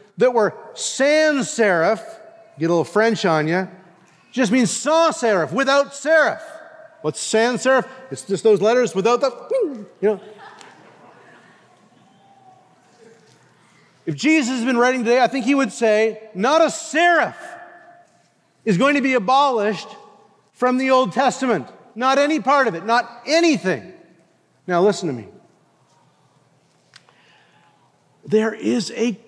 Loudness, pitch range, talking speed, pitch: -19 LUFS, 215-290 Hz, 130 wpm, 245 Hz